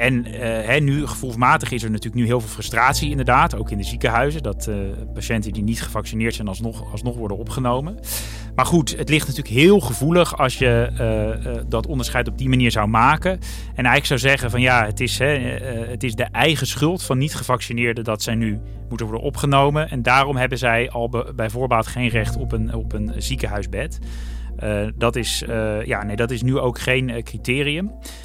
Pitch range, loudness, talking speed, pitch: 110-130 Hz, -20 LUFS, 200 wpm, 120 Hz